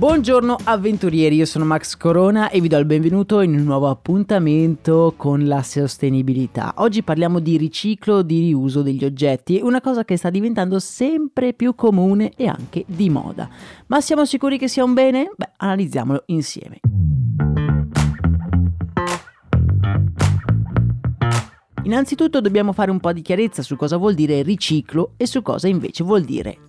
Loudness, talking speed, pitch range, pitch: -18 LUFS, 150 wpm, 140-215 Hz, 170 Hz